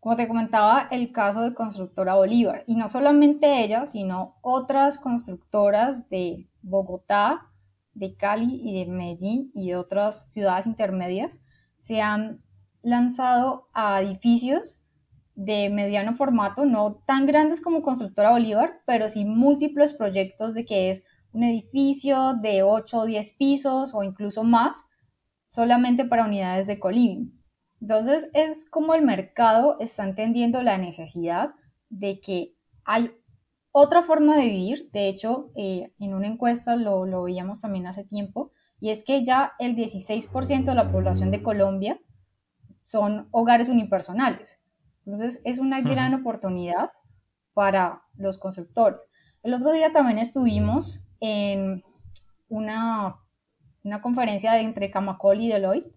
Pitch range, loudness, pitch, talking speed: 195-245 Hz, -23 LUFS, 220 Hz, 135 wpm